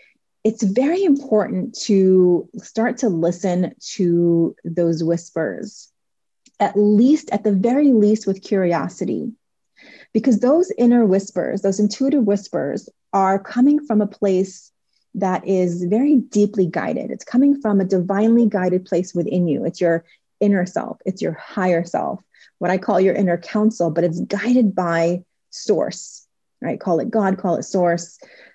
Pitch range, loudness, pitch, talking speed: 180-235 Hz, -19 LUFS, 200 Hz, 145 wpm